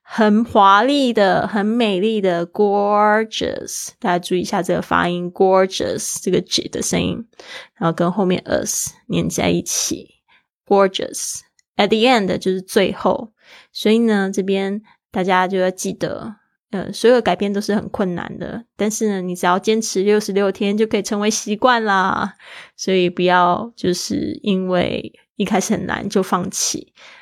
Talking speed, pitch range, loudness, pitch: 285 characters per minute, 185-220 Hz, -18 LUFS, 200 Hz